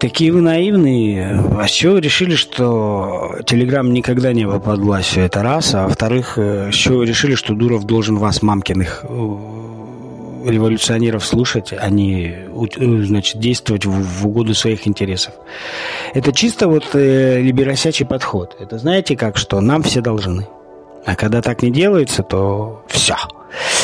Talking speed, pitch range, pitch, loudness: 135 wpm, 100-130 Hz, 115 Hz, -15 LUFS